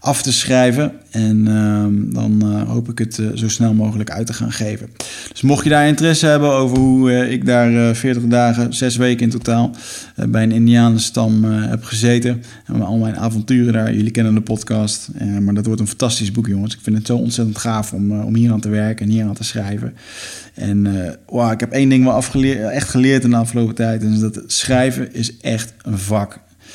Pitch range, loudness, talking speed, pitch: 110-125 Hz, -16 LUFS, 230 wpm, 115 Hz